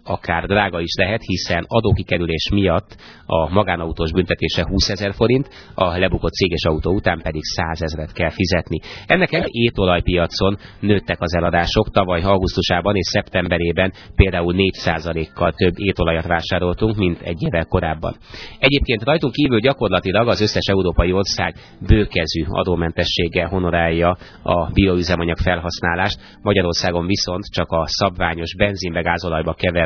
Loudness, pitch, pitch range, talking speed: -18 LUFS, 90 Hz, 85-100 Hz, 125 wpm